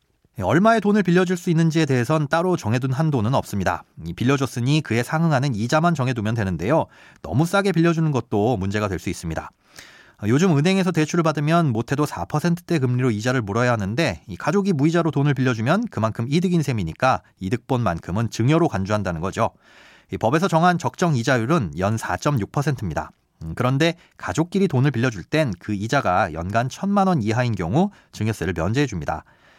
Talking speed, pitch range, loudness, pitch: 380 characters per minute, 110-165 Hz, -21 LUFS, 130 Hz